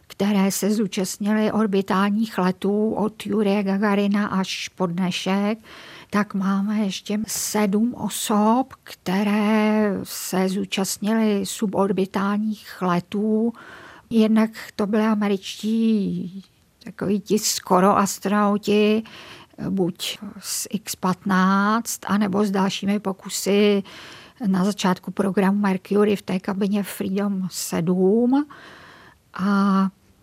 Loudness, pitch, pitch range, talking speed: -22 LUFS, 200 Hz, 190-210 Hz, 90 wpm